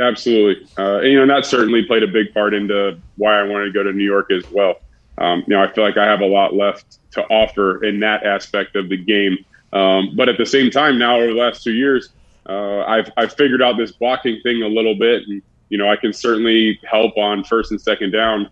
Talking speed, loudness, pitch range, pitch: 245 wpm, -16 LUFS, 100-115 Hz, 105 Hz